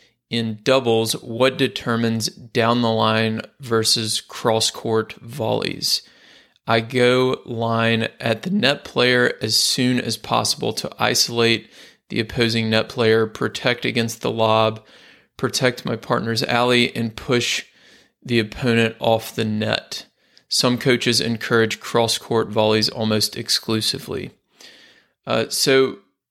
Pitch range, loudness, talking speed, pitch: 110-125 Hz, -20 LUFS, 120 wpm, 115 Hz